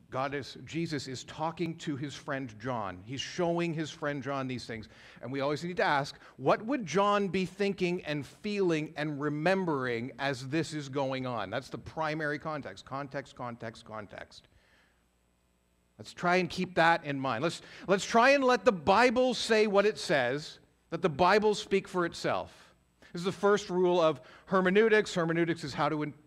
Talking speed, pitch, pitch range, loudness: 180 wpm, 155 Hz, 135-185 Hz, -30 LUFS